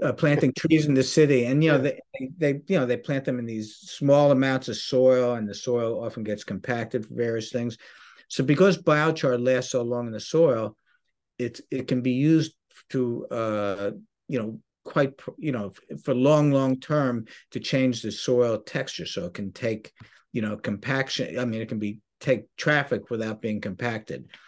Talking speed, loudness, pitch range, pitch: 190 wpm, -25 LUFS, 110-140 Hz, 125 Hz